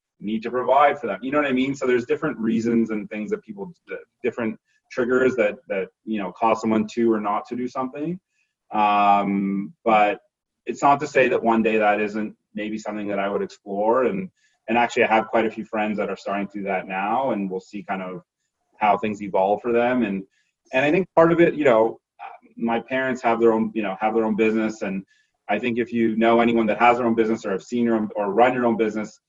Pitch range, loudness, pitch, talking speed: 105-125 Hz, -22 LUFS, 115 Hz, 240 wpm